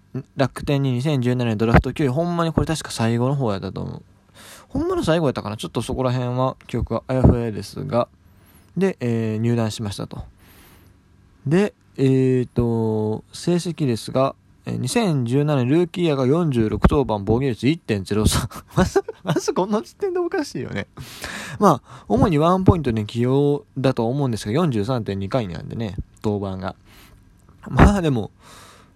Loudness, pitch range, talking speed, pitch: -21 LUFS, 105-145 Hz, 290 characters per minute, 125 Hz